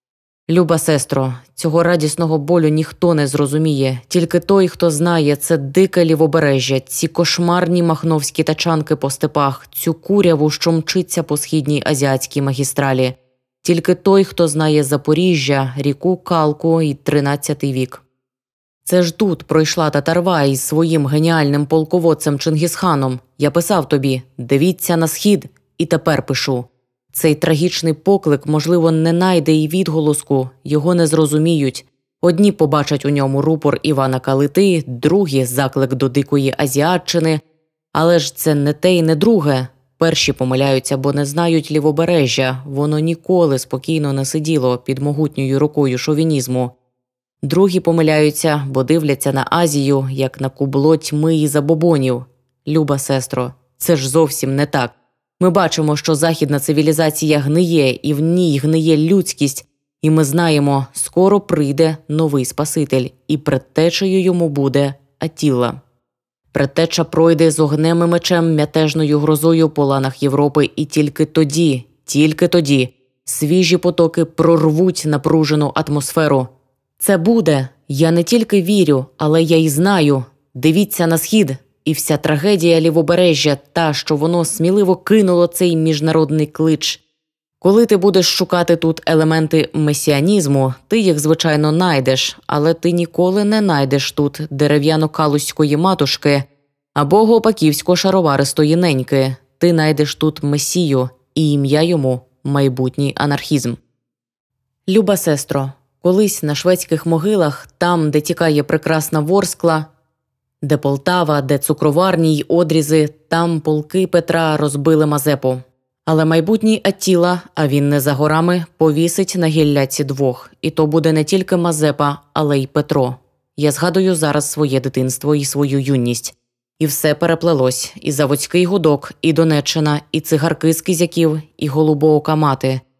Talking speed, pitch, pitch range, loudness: 130 wpm, 155 Hz, 140-165 Hz, -15 LUFS